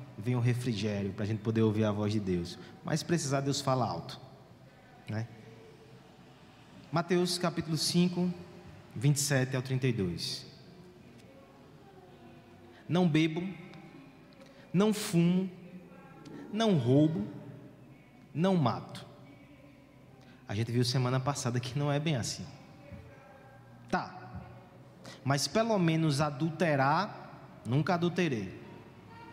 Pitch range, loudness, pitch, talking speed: 125-170 Hz, -31 LUFS, 145 Hz, 100 wpm